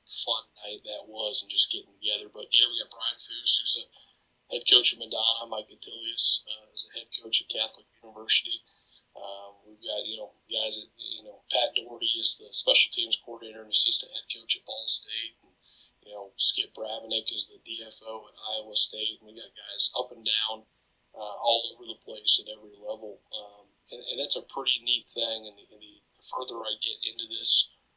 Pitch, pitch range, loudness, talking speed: 110 Hz, 105-115 Hz, -24 LUFS, 205 wpm